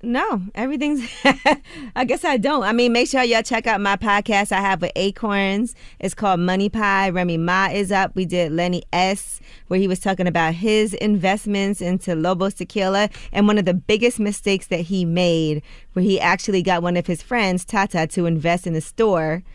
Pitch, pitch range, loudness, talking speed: 195 Hz, 180-215 Hz, -20 LUFS, 195 wpm